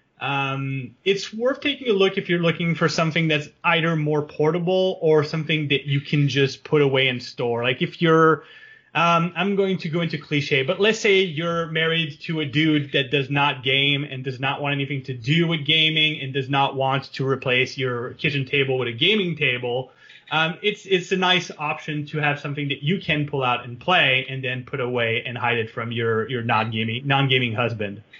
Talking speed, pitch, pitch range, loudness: 210 wpm, 145 Hz, 135-165 Hz, -21 LUFS